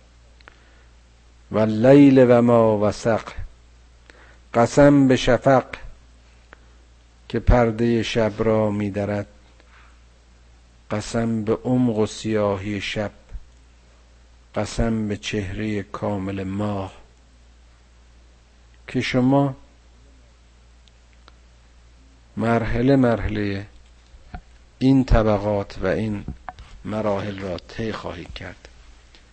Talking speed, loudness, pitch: 80 wpm, -20 LUFS, 95 Hz